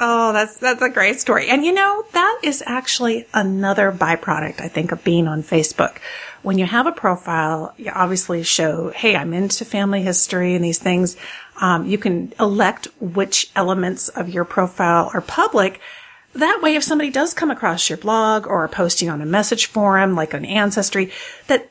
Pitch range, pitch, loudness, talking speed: 175-240 Hz, 195 Hz, -17 LUFS, 180 wpm